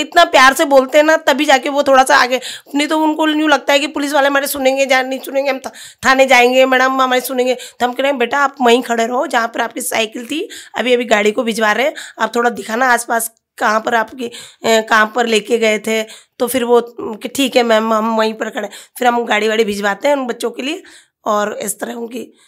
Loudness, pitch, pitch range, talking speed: -14 LUFS, 250 Hz, 230-275 Hz, 250 wpm